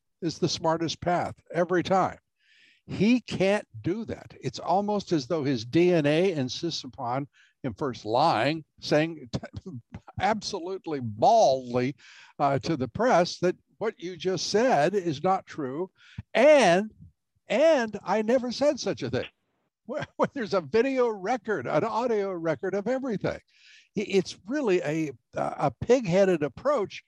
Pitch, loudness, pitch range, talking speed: 175 Hz, -26 LUFS, 145-205 Hz, 135 wpm